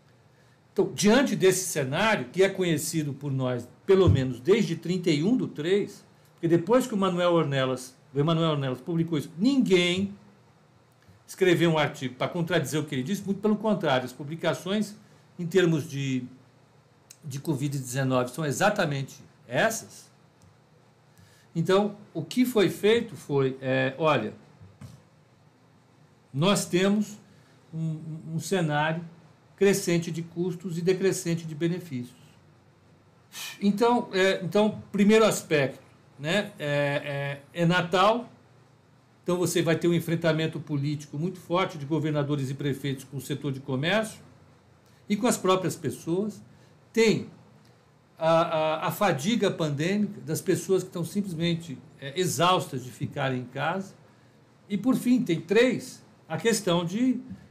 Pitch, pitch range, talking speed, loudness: 165 Hz, 140-190 Hz, 135 wpm, -26 LUFS